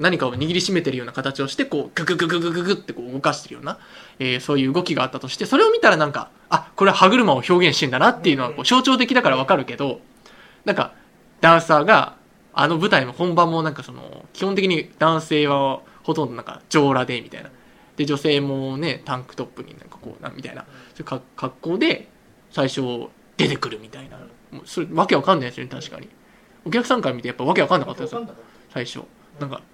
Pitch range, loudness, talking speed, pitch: 135-180 Hz, -20 LUFS, 445 characters per minute, 155 Hz